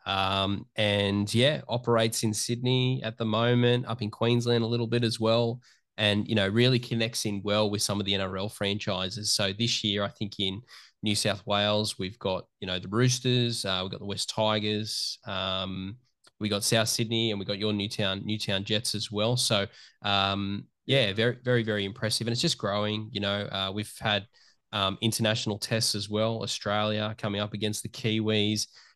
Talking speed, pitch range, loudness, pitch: 190 wpm, 100-115 Hz, -28 LUFS, 105 Hz